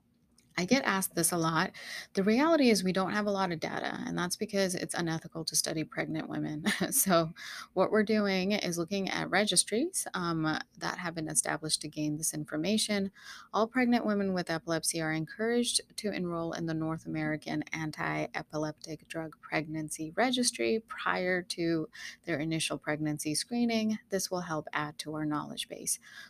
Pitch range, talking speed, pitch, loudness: 155-200 Hz, 170 wpm, 170 Hz, -31 LUFS